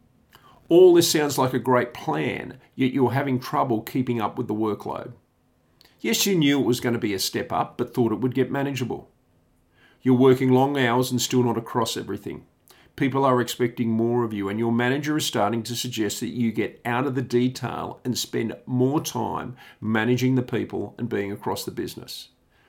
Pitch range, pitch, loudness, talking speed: 120-130 Hz, 125 Hz, -23 LUFS, 195 wpm